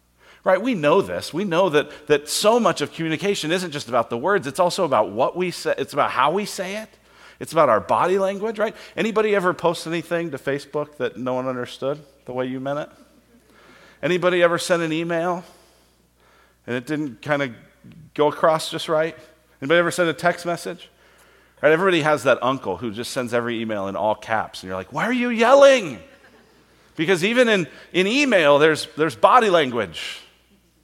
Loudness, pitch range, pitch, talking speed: -21 LUFS, 135-185 Hz, 160 Hz, 195 wpm